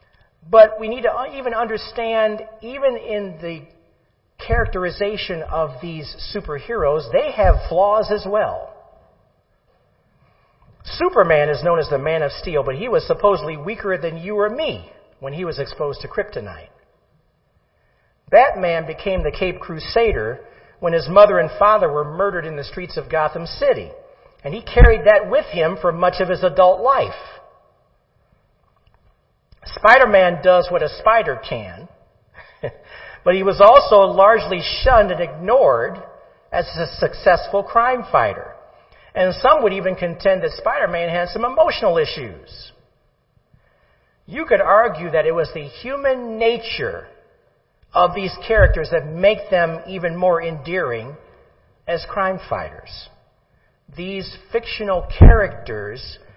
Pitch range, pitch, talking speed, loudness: 170-225 Hz, 190 Hz, 135 wpm, -17 LUFS